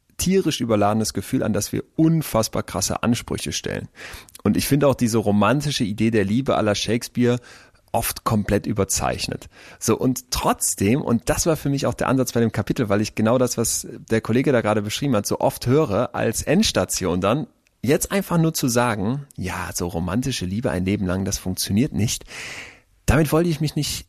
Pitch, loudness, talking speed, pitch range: 115 Hz, -21 LUFS, 185 wpm, 105-135 Hz